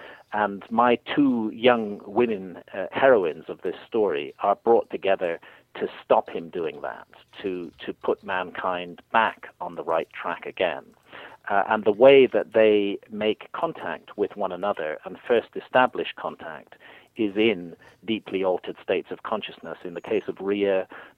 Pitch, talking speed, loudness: 110 Hz, 155 wpm, -24 LUFS